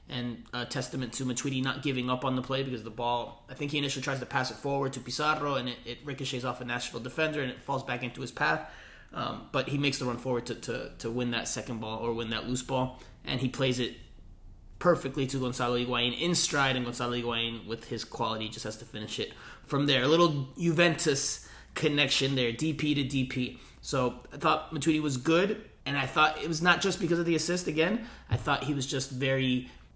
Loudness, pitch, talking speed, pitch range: -30 LUFS, 130 Hz, 230 wpm, 120-145 Hz